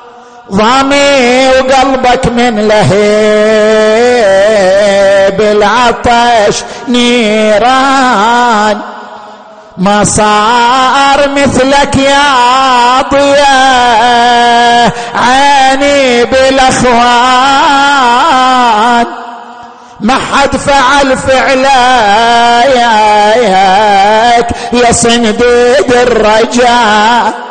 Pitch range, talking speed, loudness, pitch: 220-260 Hz, 45 wpm, -6 LUFS, 240 Hz